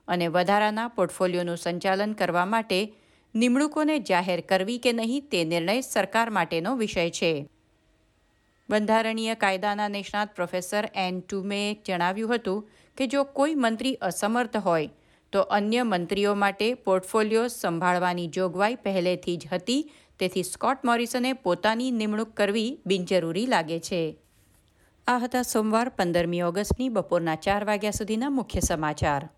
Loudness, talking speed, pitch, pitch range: -26 LUFS, 125 wpm, 200 Hz, 175-225 Hz